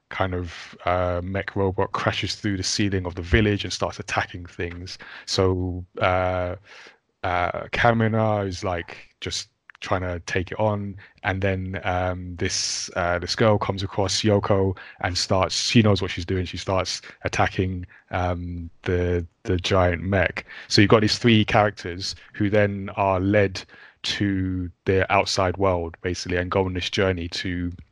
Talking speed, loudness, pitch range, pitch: 160 wpm, -23 LUFS, 90-100 Hz, 95 Hz